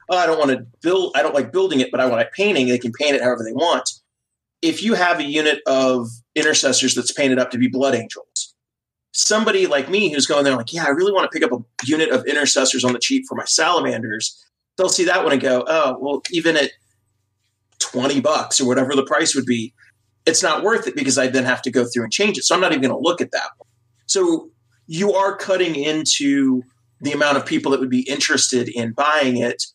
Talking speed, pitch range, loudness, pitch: 240 wpm, 125-165 Hz, -18 LUFS, 135 Hz